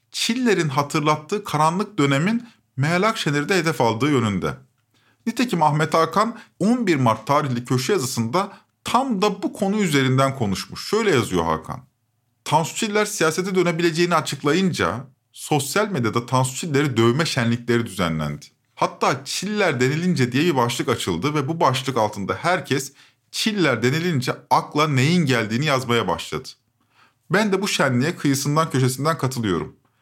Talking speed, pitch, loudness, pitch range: 130 wpm, 145 Hz, -21 LUFS, 125-175 Hz